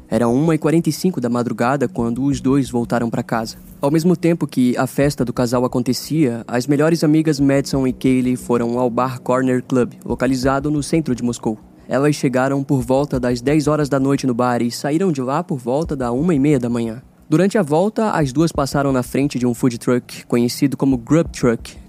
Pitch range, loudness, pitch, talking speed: 125-150 Hz, -18 LUFS, 130 Hz, 195 wpm